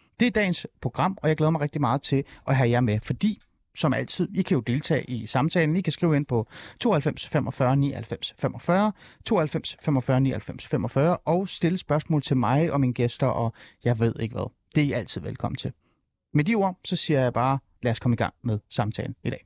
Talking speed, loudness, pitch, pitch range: 220 wpm, -25 LUFS, 140 Hz, 120-165 Hz